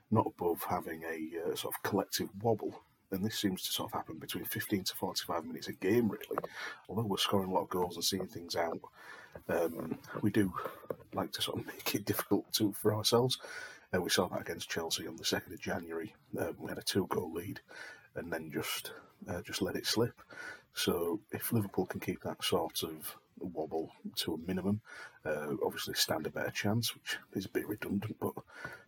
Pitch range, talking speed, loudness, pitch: 95-120 Hz, 200 wpm, -36 LUFS, 105 Hz